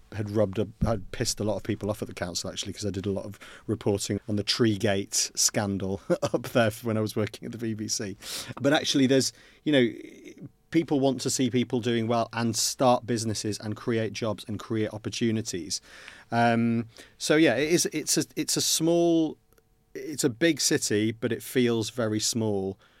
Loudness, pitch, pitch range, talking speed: -27 LUFS, 115 Hz, 105-125 Hz, 195 wpm